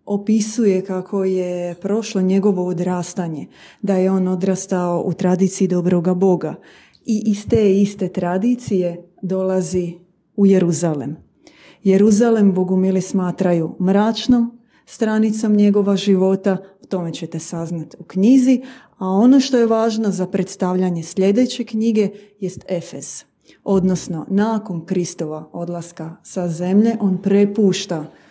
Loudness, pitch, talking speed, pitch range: -18 LUFS, 190 Hz, 115 wpm, 180-205 Hz